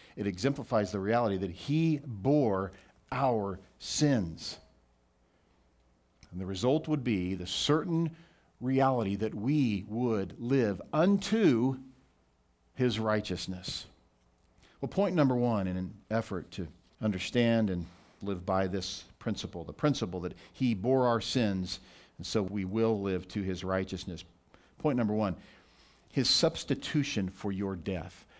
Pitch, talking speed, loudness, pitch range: 100 Hz, 130 wpm, -31 LUFS, 90-120 Hz